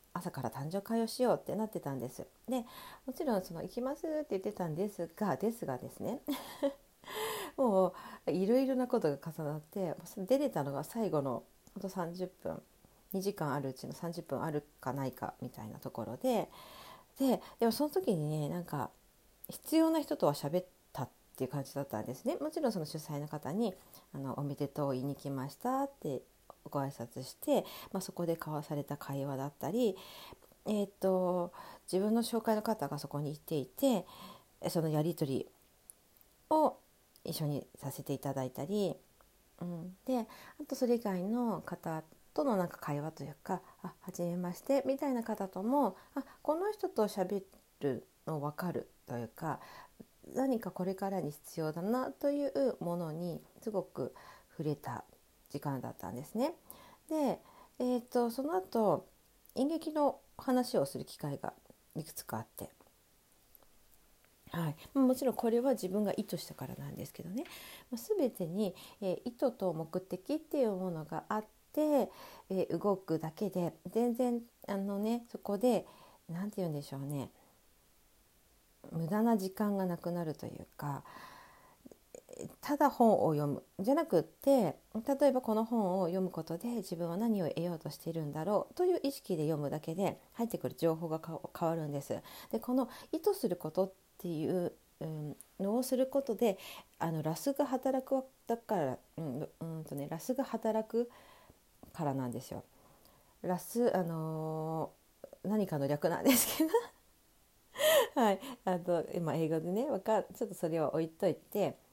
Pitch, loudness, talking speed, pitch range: 190 Hz, -36 LUFS, 295 characters per minute, 160-245 Hz